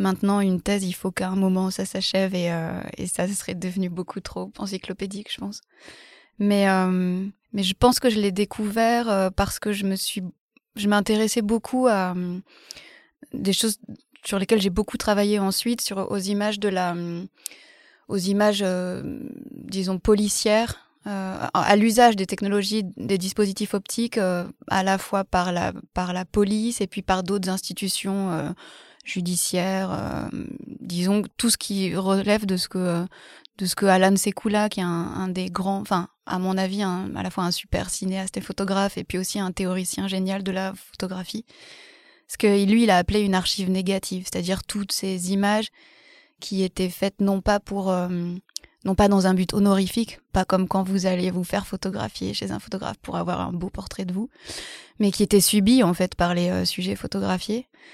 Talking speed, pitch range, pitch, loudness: 185 wpm, 185-210 Hz, 195 Hz, -24 LUFS